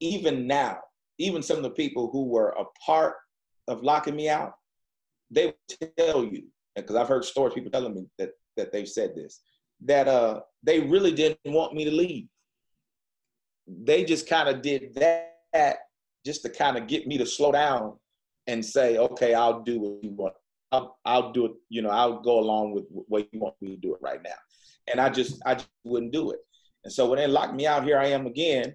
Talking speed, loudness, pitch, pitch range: 210 wpm, -26 LUFS, 140 Hz, 115-165 Hz